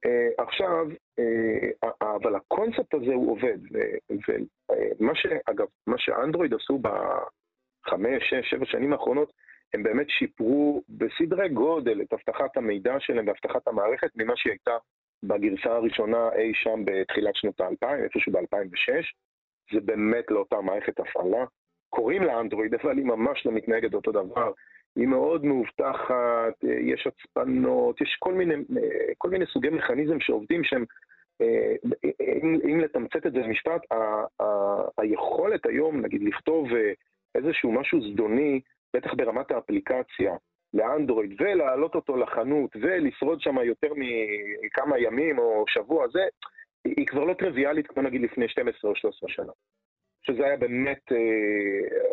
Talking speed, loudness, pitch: 130 wpm, -26 LUFS, 190 Hz